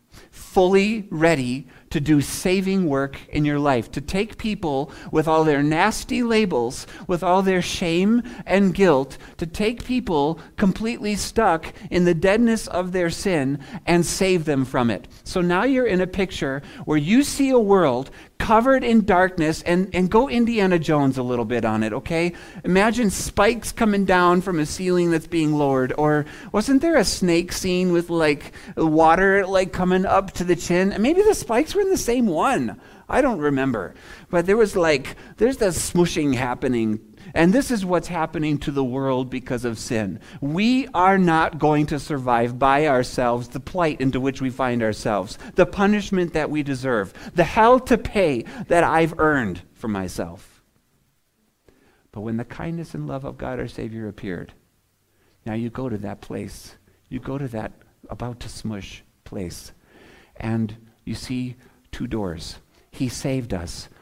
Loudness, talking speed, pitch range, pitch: -21 LUFS, 170 wpm, 130-190 Hz, 160 Hz